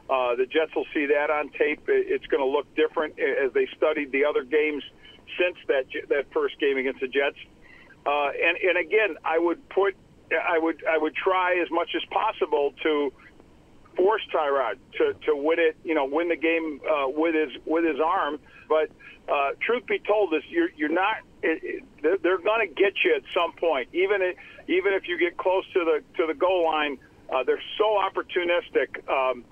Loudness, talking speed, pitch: -25 LUFS, 195 wpm, 185 Hz